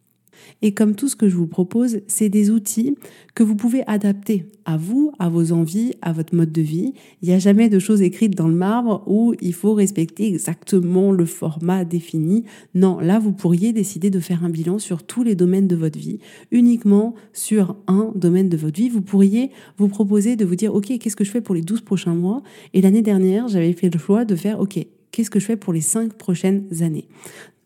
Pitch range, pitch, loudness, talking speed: 175-215 Hz, 200 Hz, -19 LUFS, 220 wpm